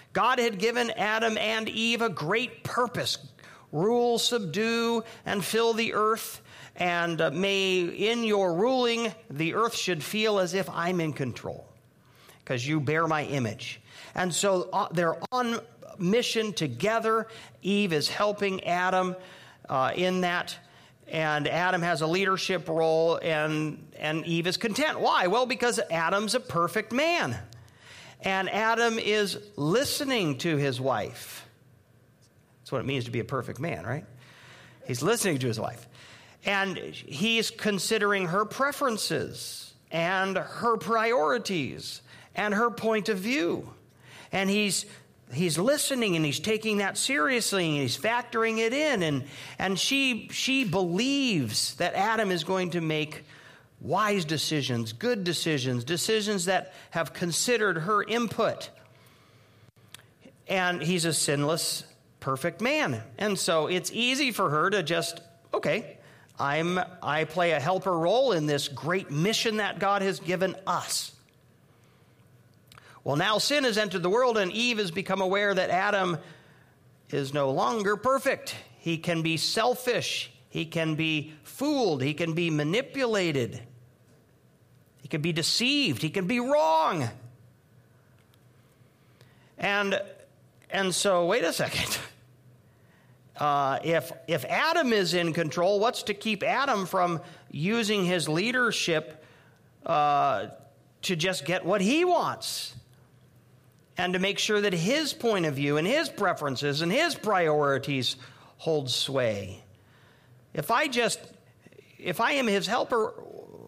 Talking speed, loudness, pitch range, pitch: 135 wpm, -27 LUFS, 140-215 Hz, 175 Hz